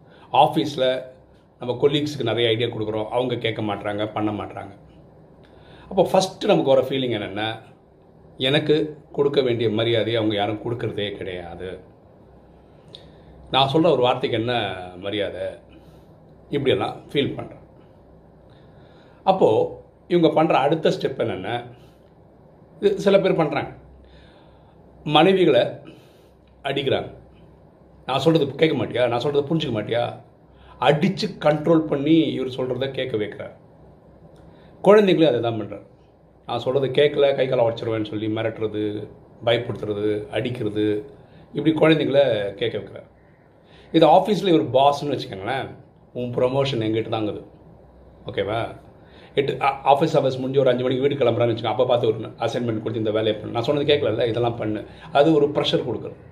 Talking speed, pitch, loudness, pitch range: 125 wpm, 130 Hz, -21 LUFS, 110-150 Hz